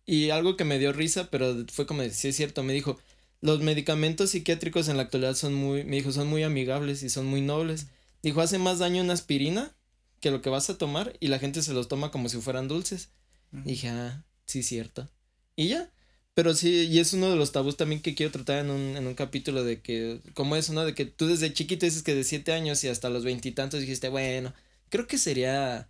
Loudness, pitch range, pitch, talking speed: -28 LUFS, 130-160 Hz, 145 Hz, 235 wpm